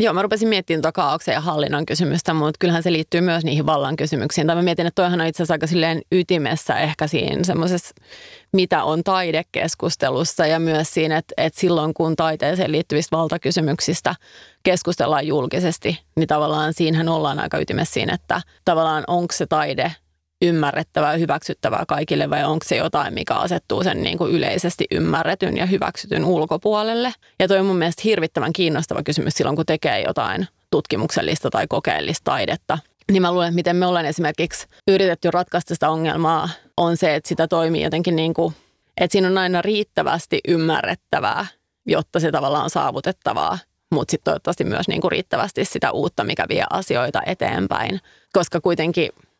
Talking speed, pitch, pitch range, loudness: 165 wpm, 170 Hz, 160-180 Hz, -20 LUFS